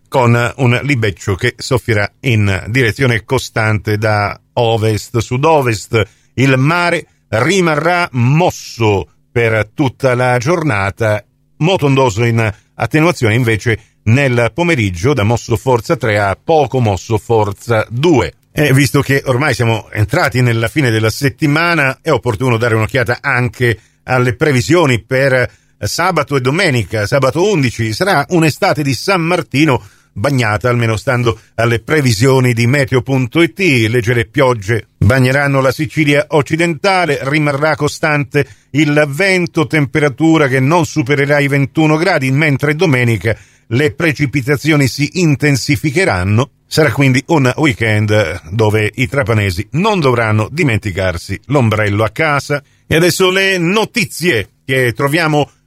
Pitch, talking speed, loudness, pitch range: 130 Hz, 120 wpm, -13 LUFS, 115-150 Hz